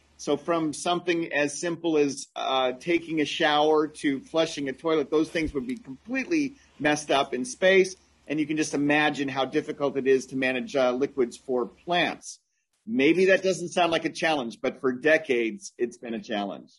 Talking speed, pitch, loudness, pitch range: 185 wpm, 155 Hz, -26 LUFS, 135-175 Hz